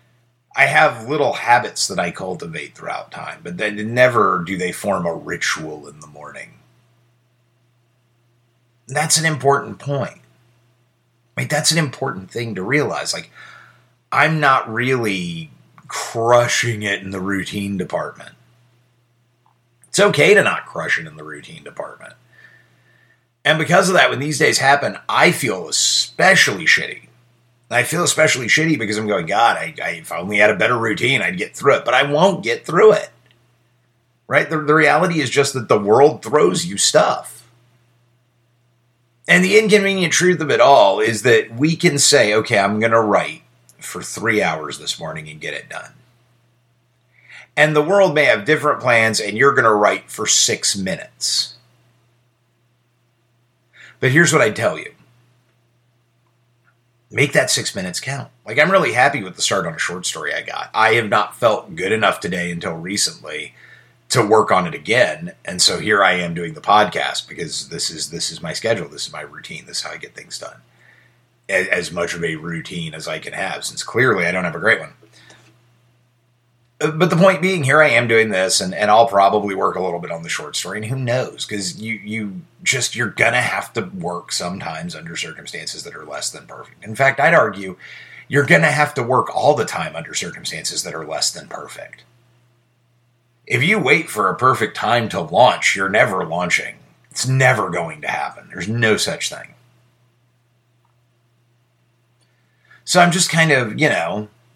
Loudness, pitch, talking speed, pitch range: -17 LUFS, 120 Hz, 180 wpm, 115-130 Hz